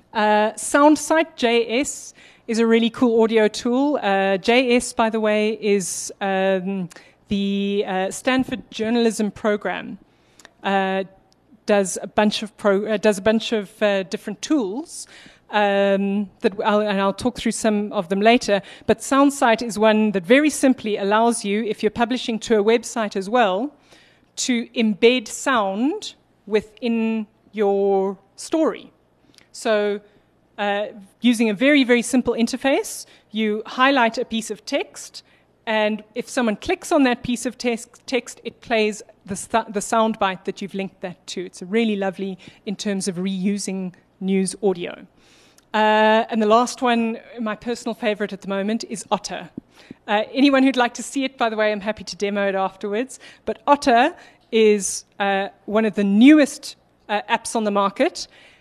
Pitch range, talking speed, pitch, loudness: 205-240 Hz, 160 wpm, 220 Hz, -20 LUFS